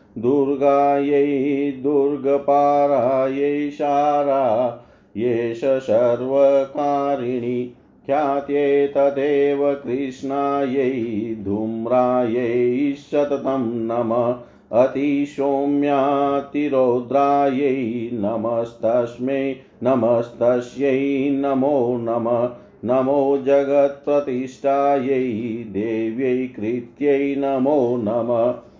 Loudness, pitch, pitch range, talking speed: -20 LUFS, 135 Hz, 120-140 Hz, 45 wpm